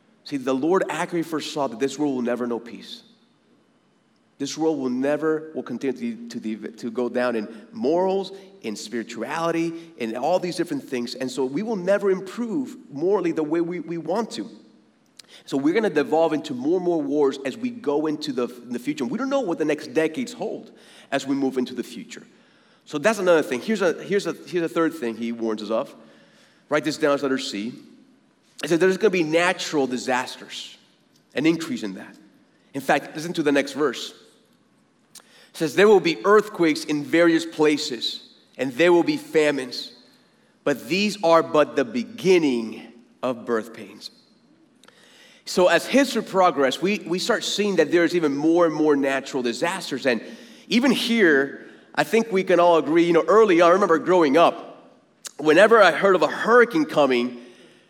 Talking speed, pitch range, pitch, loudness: 190 wpm, 135-195 Hz, 165 Hz, -22 LUFS